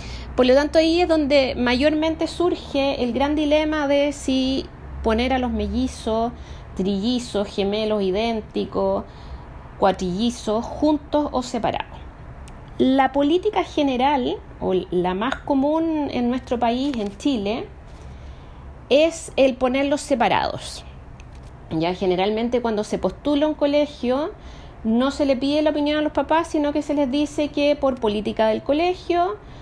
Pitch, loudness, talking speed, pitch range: 260 Hz, -21 LUFS, 135 wpm, 210-295 Hz